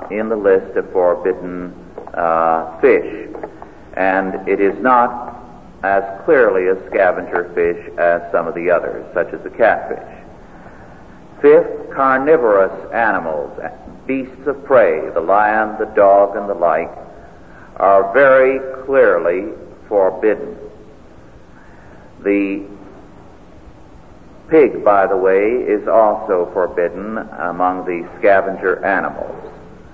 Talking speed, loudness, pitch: 110 wpm, -15 LUFS, 130 Hz